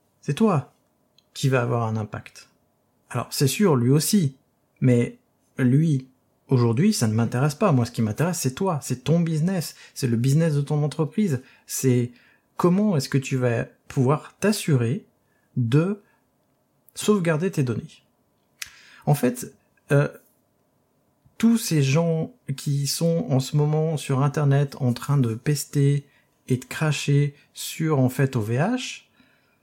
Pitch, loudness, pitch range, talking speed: 140 Hz, -23 LUFS, 125-160 Hz, 140 wpm